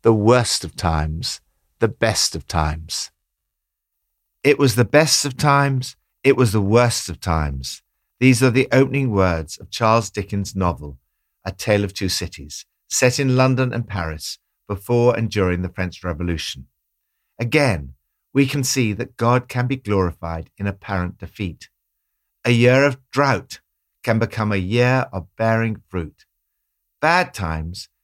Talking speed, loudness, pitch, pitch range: 150 wpm, -19 LUFS, 105 Hz, 90-125 Hz